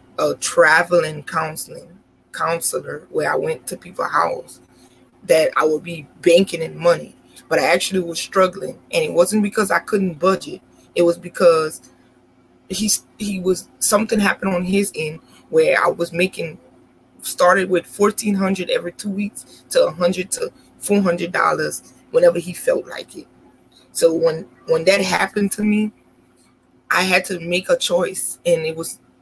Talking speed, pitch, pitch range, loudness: 160 wpm, 185 Hz, 170-210 Hz, -19 LUFS